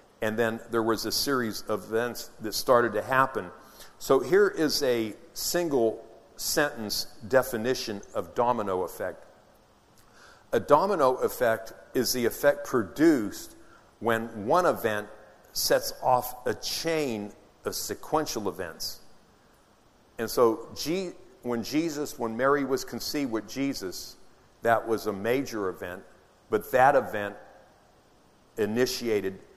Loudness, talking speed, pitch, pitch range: -27 LUFS, 120 wpm, 120 Hz, 115-145 Hz